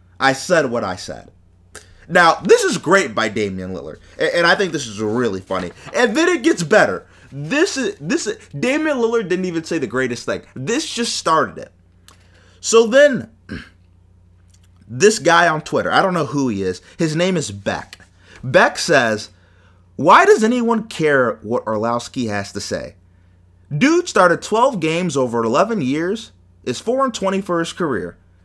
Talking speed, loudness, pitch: 170 wpm, -17 LUFS, 130 Hz